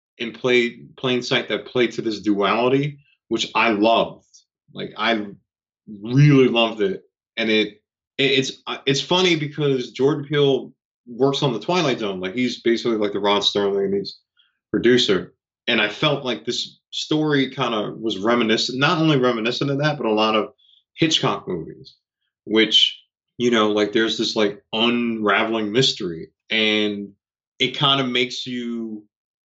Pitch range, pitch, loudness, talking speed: 110-135 Hz, 120 Hz, -20 LUFS, 155 wpm